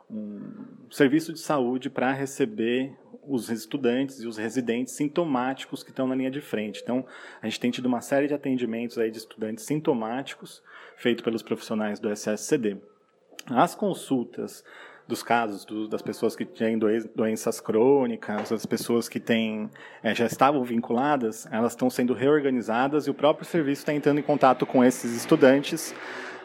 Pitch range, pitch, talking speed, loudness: 115-145 Hz, 125 Hz, 160 wpm, -26 LUFS